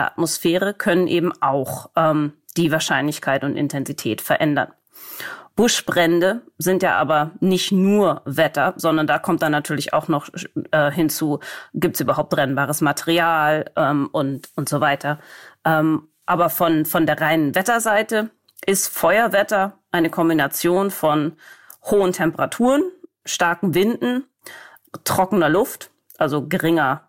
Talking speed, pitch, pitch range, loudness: 125 wpm, 165 Hz, 150-190 Hz, -19 LUFS